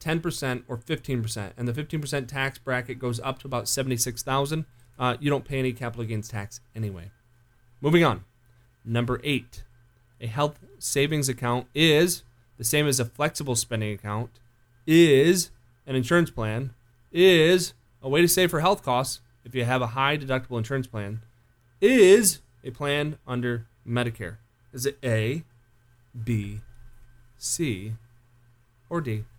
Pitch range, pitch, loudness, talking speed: 120-140 Hz, 120 Hz, -25 LUFS, 145 wpm